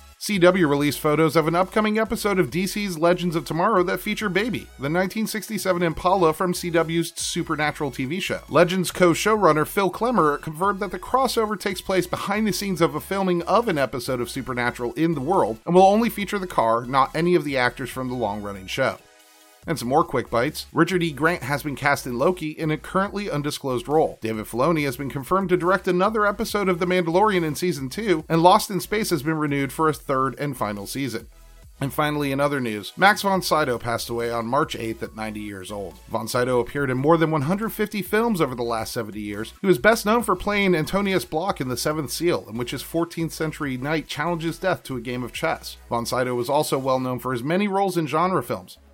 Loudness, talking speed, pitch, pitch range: -23 LUFS, 215 wpm, 160 Hz, 130-185 Hz